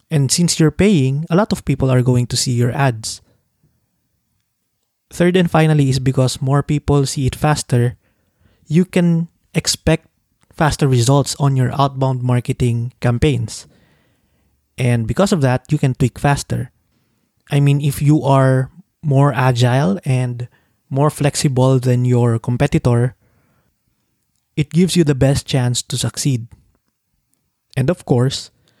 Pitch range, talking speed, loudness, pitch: 125-150 Hz, 140 wpm, -16 LUFS, 135 Hz